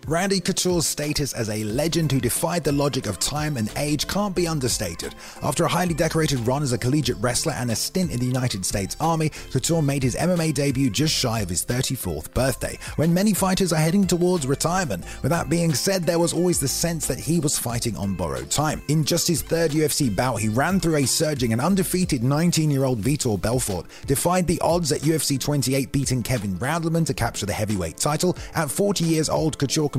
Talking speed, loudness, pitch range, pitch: 210 wpm, -22 LUFS, 125-165 Hz, 145 Hz